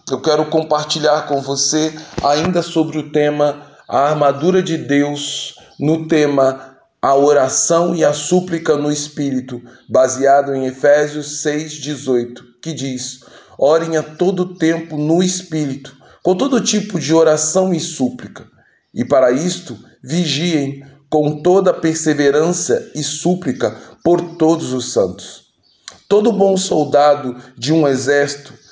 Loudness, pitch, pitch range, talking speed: -16 LUFS, 150 Hz, 140-165 Hz, 125 wpm